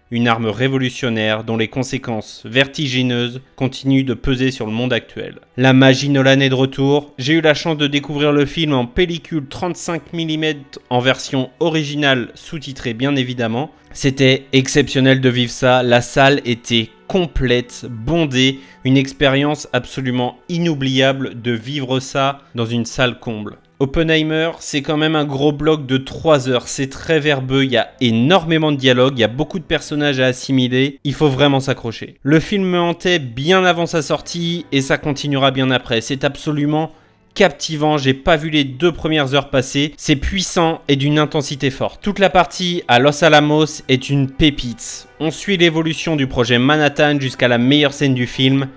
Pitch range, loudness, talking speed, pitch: 130-155 Hz, -16 LUFS, 175 wpm, 140 Hz